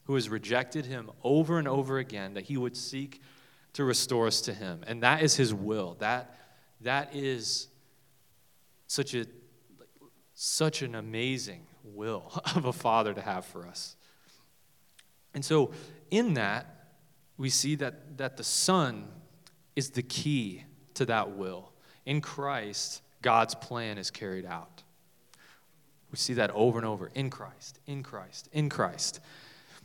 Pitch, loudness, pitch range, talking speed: 130 Hz, -31 LUFS, 115-145 Hz, 145 wpm